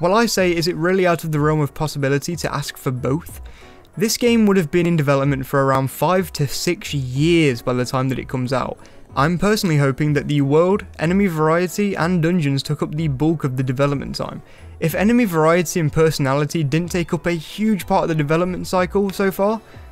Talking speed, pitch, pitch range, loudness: 215 wpm, 160 Hz, 140-180 Hz, -19 LUFS